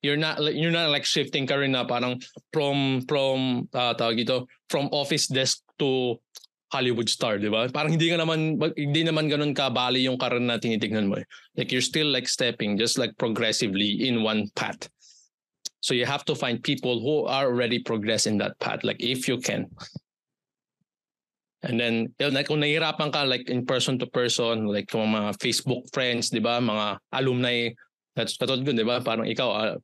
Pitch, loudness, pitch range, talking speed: 125 Hz, -25 LUFS, 120-145 Hz, 185 wpm